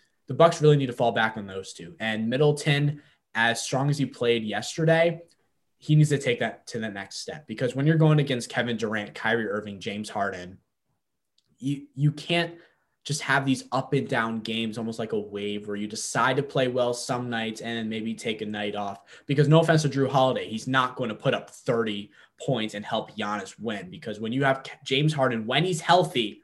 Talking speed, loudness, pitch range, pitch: 210 wpm, -26 LUFS, 110-145 Hz, 130 Hz